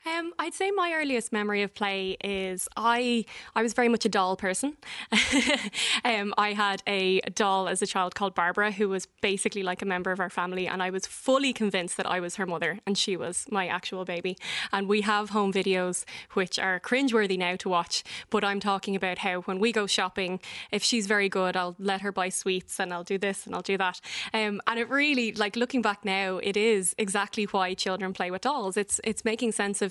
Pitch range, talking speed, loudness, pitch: 185-220 Hz, 220 wpm, -27 LUFS, 200 Hz